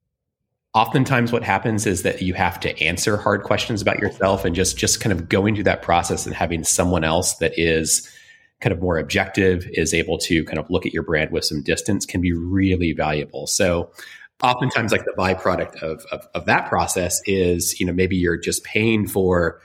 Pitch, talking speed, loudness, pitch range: 95 Hz, 200 wpm, -20 LUFS, 85-105 Hz